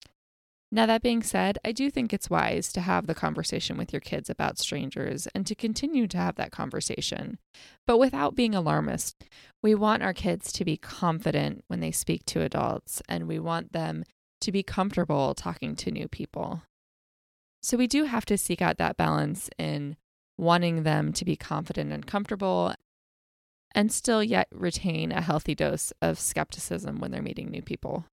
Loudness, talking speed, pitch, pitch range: -28 LUFS, 175 wpm, 190 Hz, 155-225 Hz